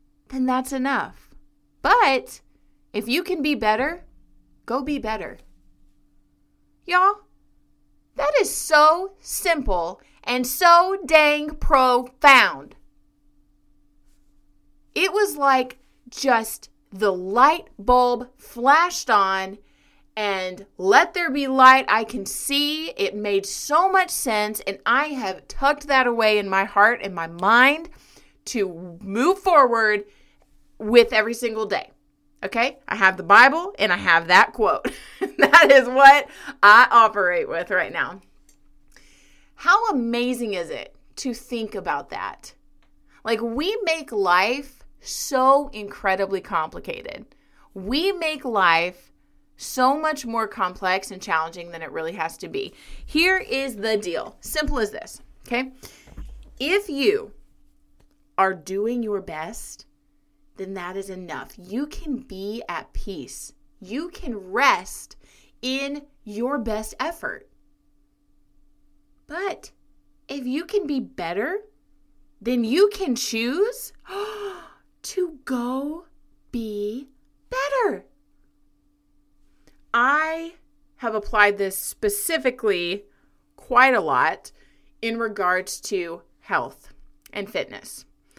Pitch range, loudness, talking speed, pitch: 190-295 Hz, -20 LUFS, 115 wpm, 240 Hz